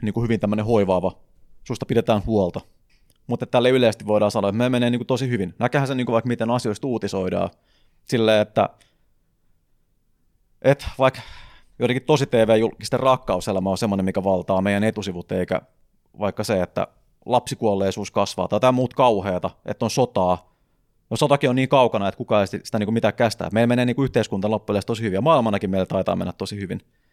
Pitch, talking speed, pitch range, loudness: 110 Hz, 180 wpm, 95-120 Hz, -21 LUFS